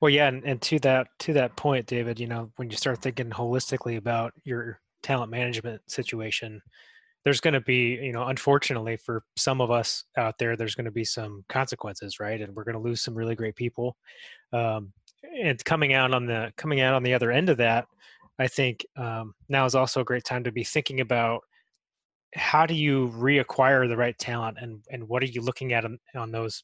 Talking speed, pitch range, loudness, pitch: 215 wpm, 115-130 Hz, -26 LUFS, 120 Hz